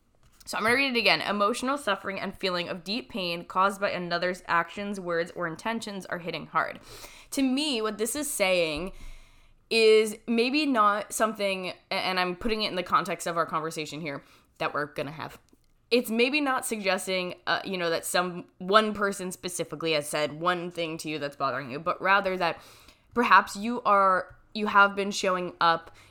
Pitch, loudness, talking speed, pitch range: 185 Hz, -27 LUFS, 190 wpm, 170-215 Hz